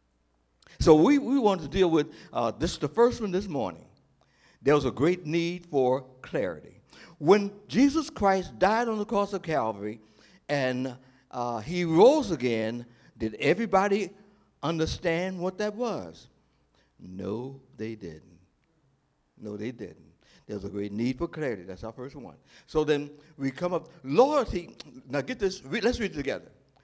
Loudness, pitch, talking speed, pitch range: -27 LUFS, 150 Hz, 160 wpm, 120-190 Hz